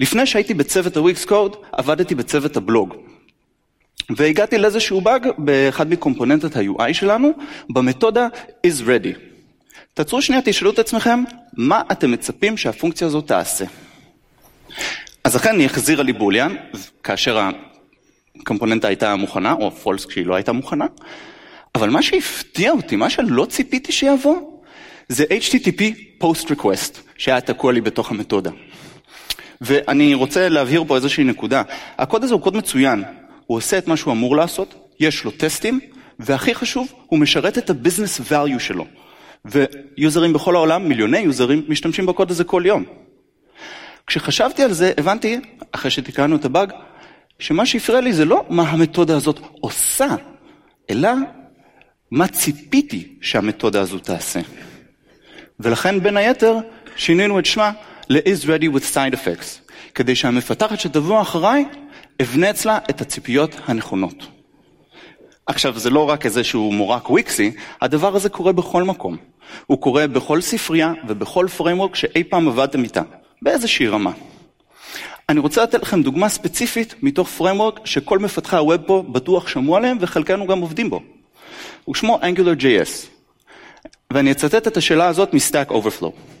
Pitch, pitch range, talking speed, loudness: 185 Hz, 150-235 Hz, 135 wpm, -18 LUFS